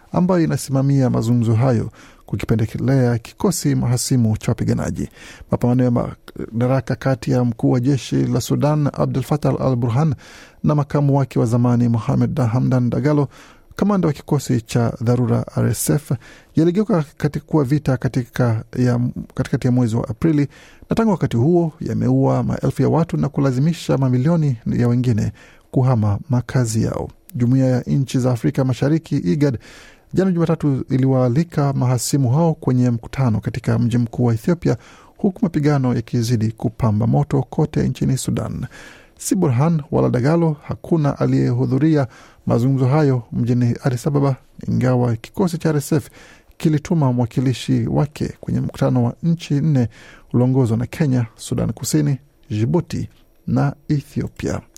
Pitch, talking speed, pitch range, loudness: 130 Hz, 130 wpm, 120-150 Hz, -19 LUFS